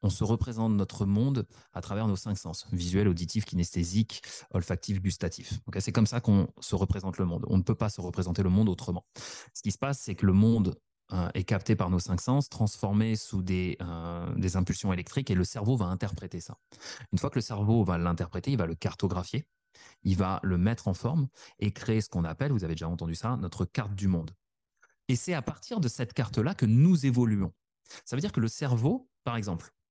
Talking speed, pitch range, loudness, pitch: 220 wpm, 90-115 Hz, -30 LUFS, 100 Hz